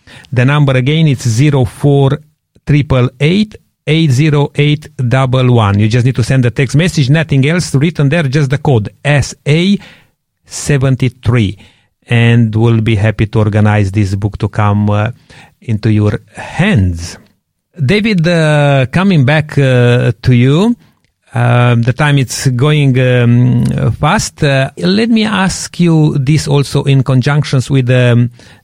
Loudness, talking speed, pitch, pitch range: -11 LUFS, 150 wpm, 130 Hz, 115-150 Hz